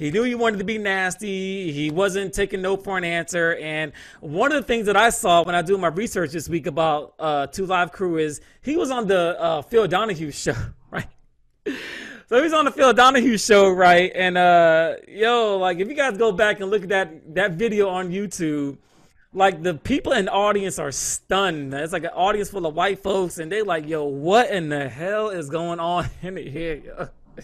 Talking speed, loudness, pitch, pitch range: 220 wpm, -21 LUFS, 185 Hz, 165-205 Hz